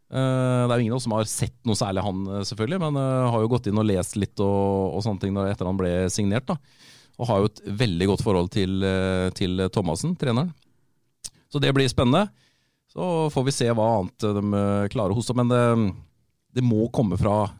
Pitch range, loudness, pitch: 100-130 Hz, -24 LUFS, 110 Hz